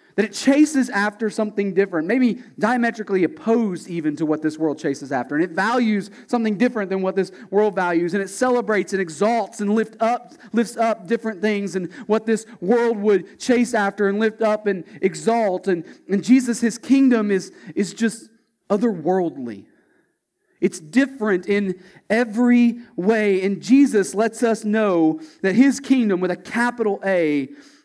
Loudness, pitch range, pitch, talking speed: -20 LUFS, 190-235 Hz, 210 Hz, 165 wpm